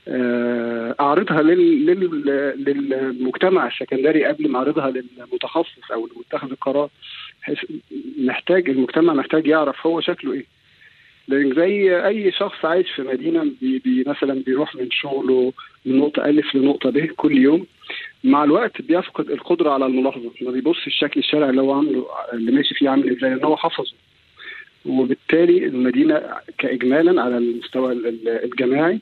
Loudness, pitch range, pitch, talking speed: -19 LUFS, 130-195 Hz, 150 Hz, 130 wpm